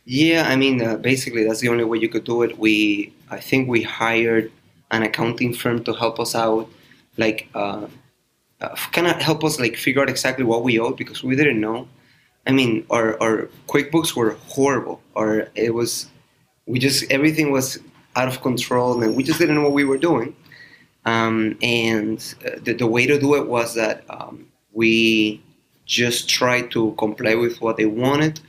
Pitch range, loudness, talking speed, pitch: 110-135 Hz, -20 LUFS, 190 wpm, 120 Hz